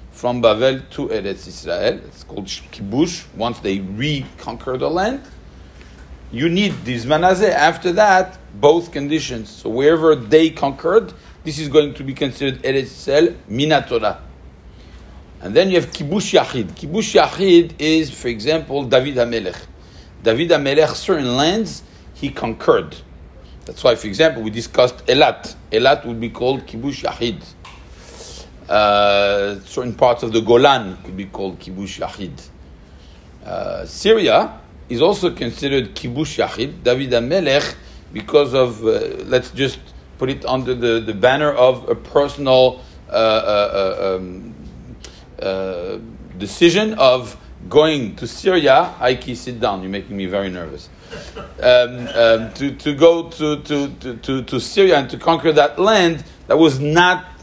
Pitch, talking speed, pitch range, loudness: 125 Hz, 140 wpm, 100-150 Hz, -17 LUFS